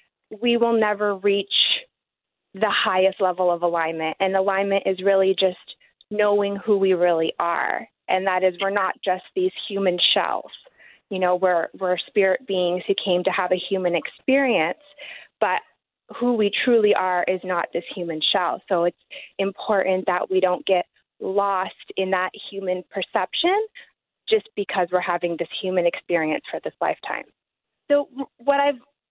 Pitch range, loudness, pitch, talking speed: 180-210 Hz, -22 LUFS, 190 Hz, 155 wpm